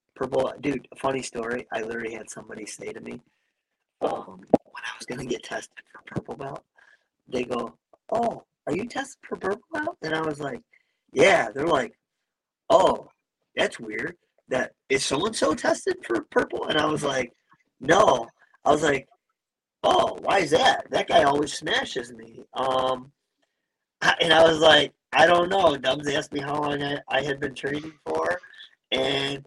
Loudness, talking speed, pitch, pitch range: -24 LUFS, 175 wpm, 150 Hz, 135-230 Hz